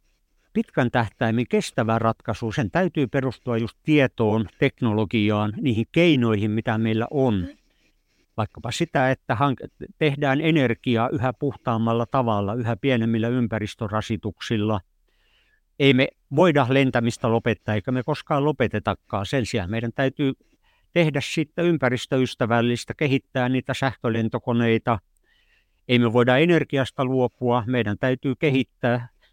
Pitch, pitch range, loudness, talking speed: 125 Hz, 115-140 Hz, -23 LUFS, 110 wpm